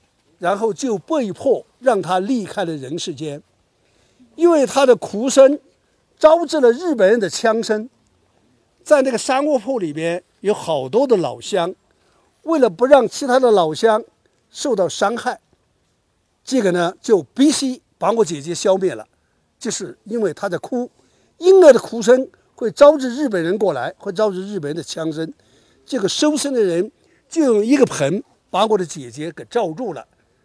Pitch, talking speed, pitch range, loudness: 225 Hz, 230 characters per minute, 185-270 Hz, -17 LUFS